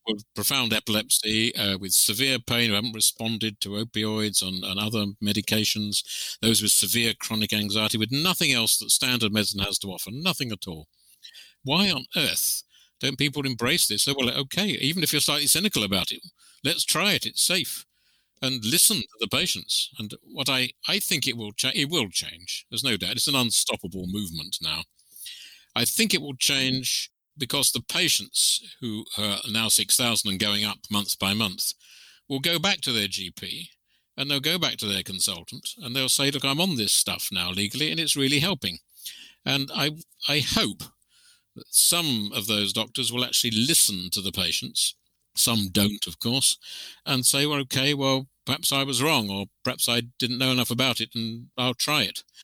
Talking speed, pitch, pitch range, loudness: 190 wpm, 120 Hz, 105-140 Hz, -23 LUFS